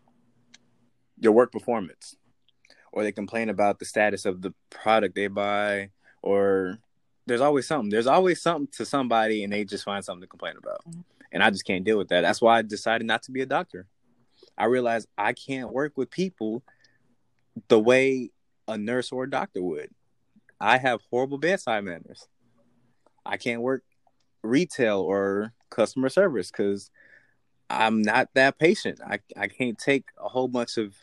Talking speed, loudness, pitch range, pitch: 170 wpm, -25 LUFS, 105-130 Hz, 115 Hz